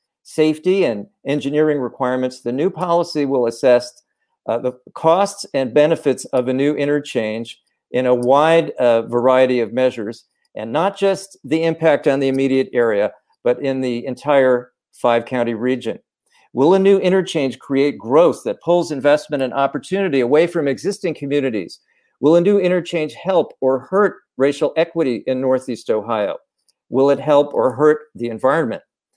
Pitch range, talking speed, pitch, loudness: 125-160 Hz, 155 wpm, 140 Hz, -18 LUFS